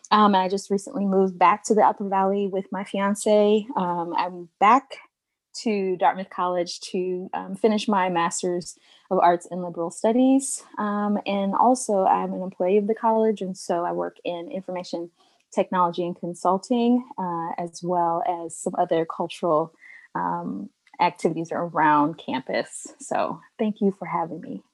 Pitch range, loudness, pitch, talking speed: 175-205 Hz, -24 LUFS, 185 Hz, 155 wpm